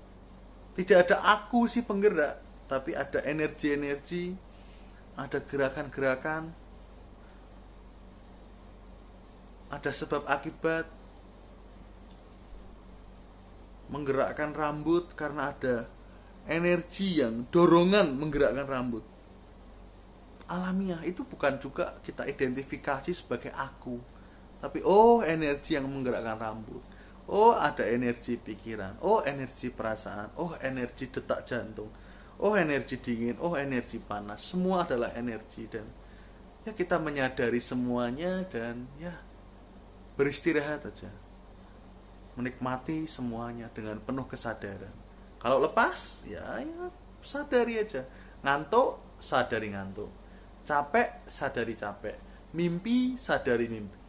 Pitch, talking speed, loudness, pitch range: 130 Hz, 95 wpm, -30 LUFS, 110-160 Hz